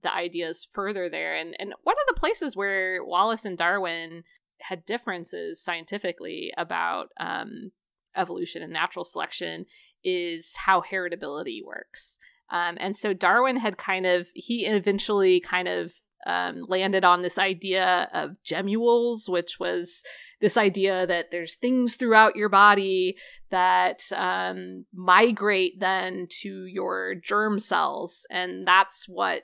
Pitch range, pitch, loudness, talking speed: 175-210 Hz, 190 Hz, -25 LUFS, 135 wpm